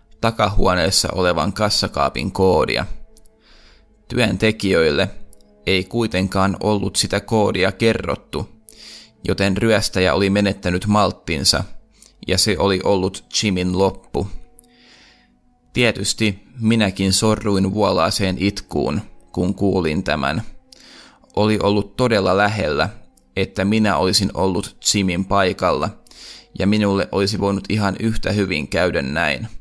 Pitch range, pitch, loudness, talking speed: 95-105 Hz, 100 Hz, -19 LUFS, 100 wpm